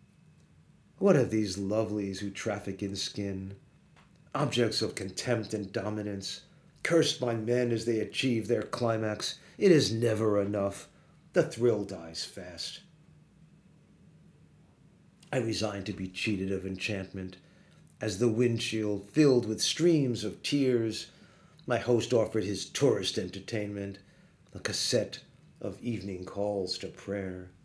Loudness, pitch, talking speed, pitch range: -30 LUFS, 110 Hz, 125 wpm, 100-145 Hz